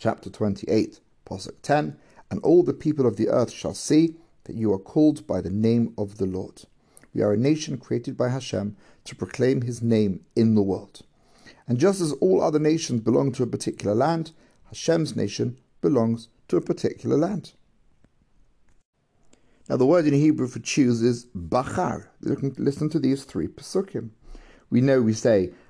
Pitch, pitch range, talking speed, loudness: 125 Hz, 110-150 Hz, 175 wpm, -24 LUFS